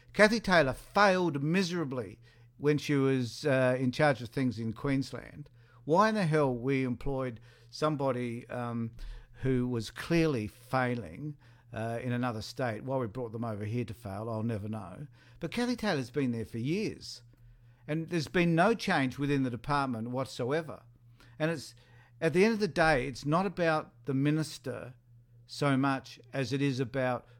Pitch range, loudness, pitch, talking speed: 120-150 Hz, -31 LUFS, 130 Hz, 165 wpm